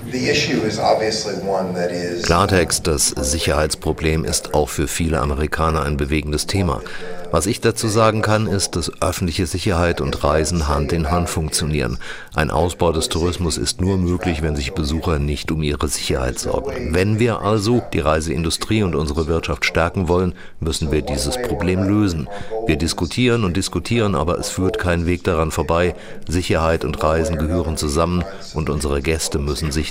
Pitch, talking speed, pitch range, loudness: 85 Hz, 155 wpm, 75-95 Hz, -19 LUFS